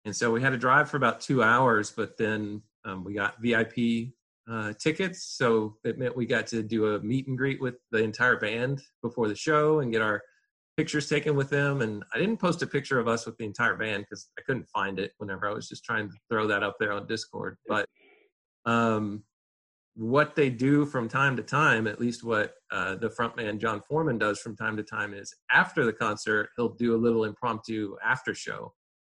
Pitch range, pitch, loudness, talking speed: 110-140 Hz, 115 Hz, -28 LUFS, 215 wpm